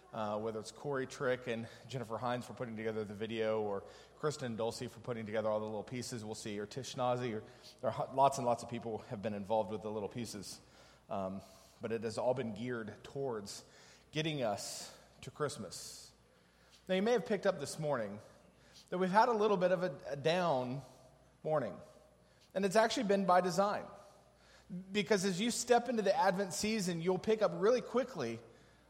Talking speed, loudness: 190 wpm, -36 LUFS